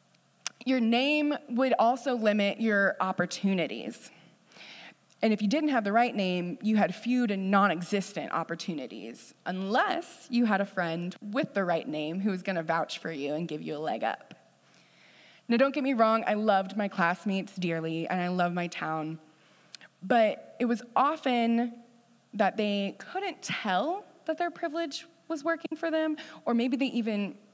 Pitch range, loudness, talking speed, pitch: 185-260 Hz, -29 LUFS, 170 wpm, 215 Hz